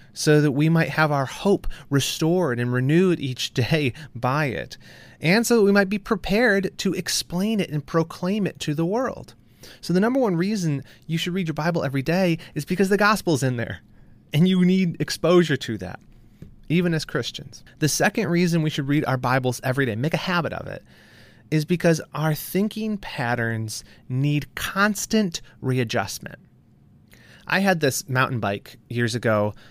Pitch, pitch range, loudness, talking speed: 155 Hz, 130-180 Hz, -23 LUFS, 175 wpm